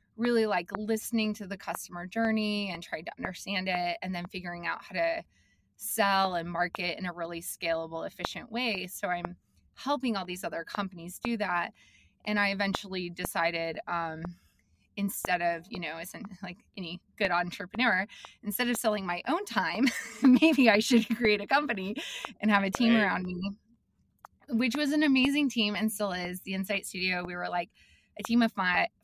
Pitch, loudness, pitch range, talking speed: 195 Hz, -30 LUFS, 175-225 Hz, 180 wpm